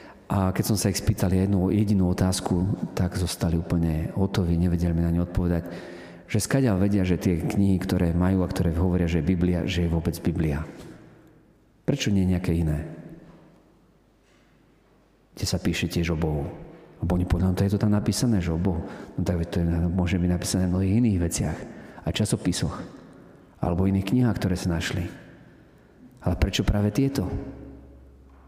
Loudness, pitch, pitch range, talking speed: -25 LUFS, 90 Hz, 85-100 Hz, 170 wpm